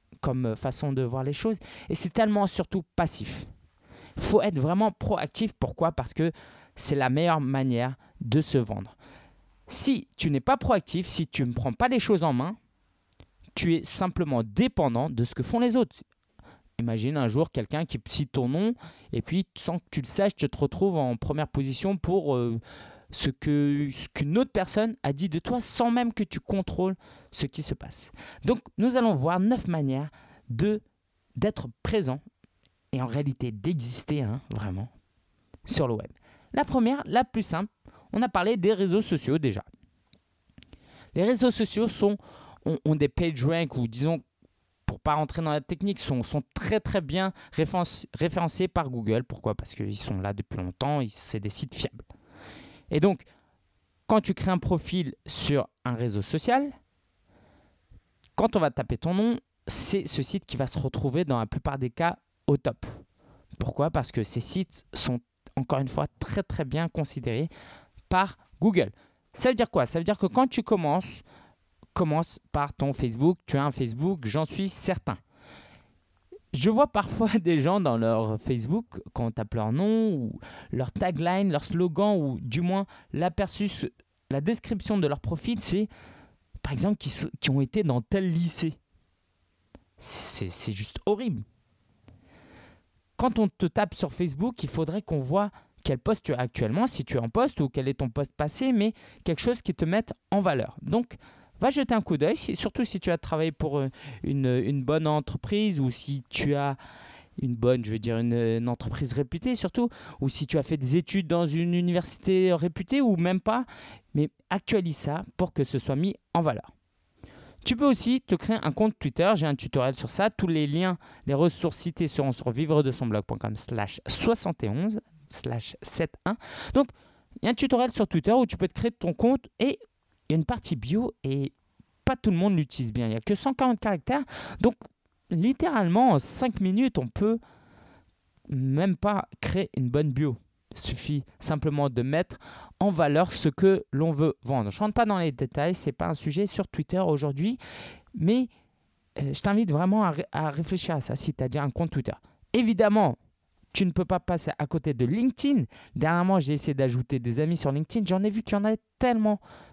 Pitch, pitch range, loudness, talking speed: 155 Hz, 130-195 Hz, -27 LUFS, 190 wpm